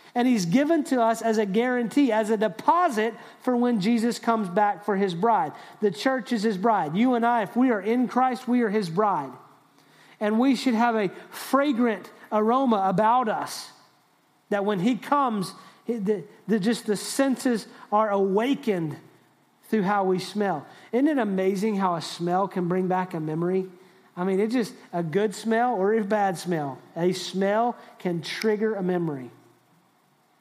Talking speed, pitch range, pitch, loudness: 175 wpm, 190-235 Hz, 220 Hz, -25 LUFS